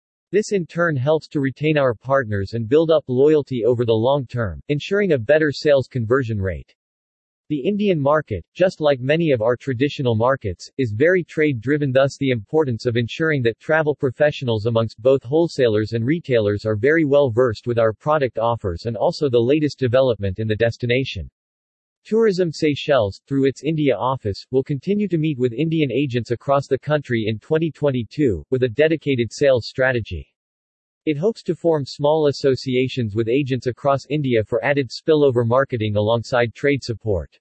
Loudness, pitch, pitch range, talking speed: -20 LUFS, 135 Hz, 115-150 Hz, 170 wpm